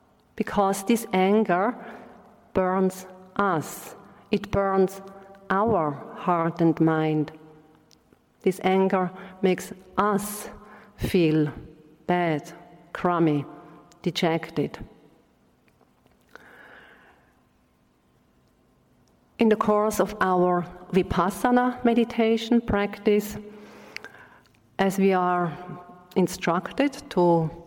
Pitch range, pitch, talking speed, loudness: 170-210 Hz, 185 Hz, 70 wpm, -24 LUFS